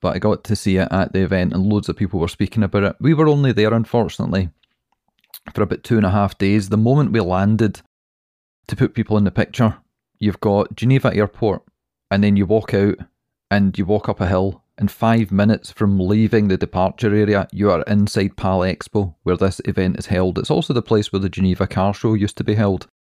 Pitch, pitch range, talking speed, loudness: 100 Hz, 95-110 Hz, 220 wpm, -18 LUFS